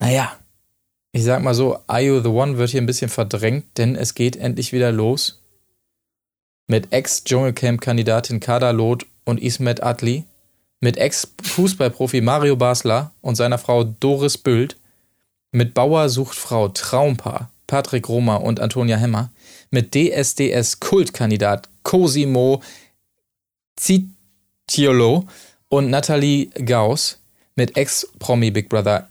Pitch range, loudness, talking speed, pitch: 115-135 Hz, -18 LUFS, 115 wpm, 120 Hz